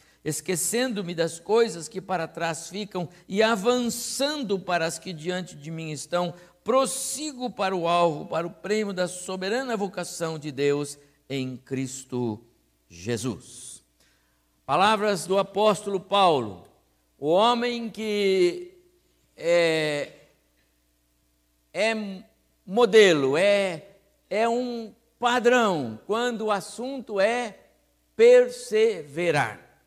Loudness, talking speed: -25 LUFS, 100 wpm